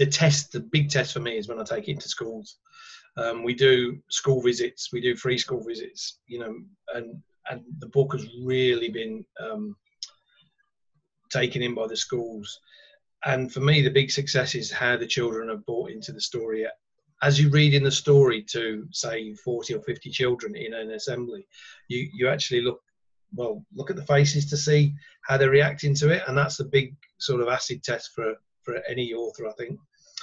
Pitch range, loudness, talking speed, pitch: 120-160 Hz, -25 LUFS, 195 wpm, 135 Hz